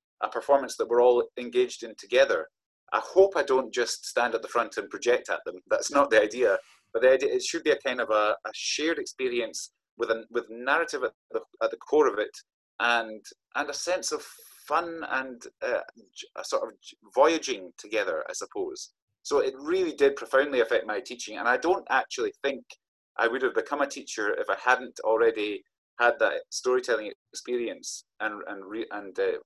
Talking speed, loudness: 195 wpm, -27 LUFS